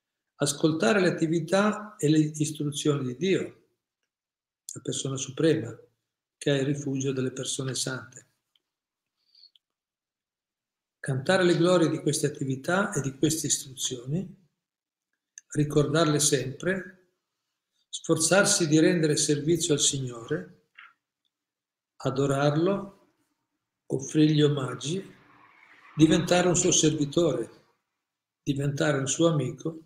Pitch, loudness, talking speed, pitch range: 150 Hz, -26 LUFS, 95 wpm, 140-170 Hz